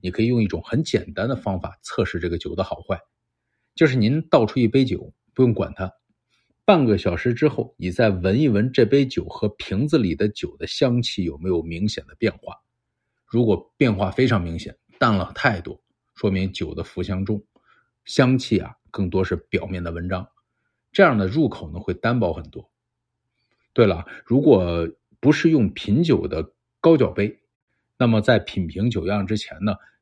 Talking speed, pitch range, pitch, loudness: 255 characters per minute, 95-120 Hz, 105 Hz, -22 LUFS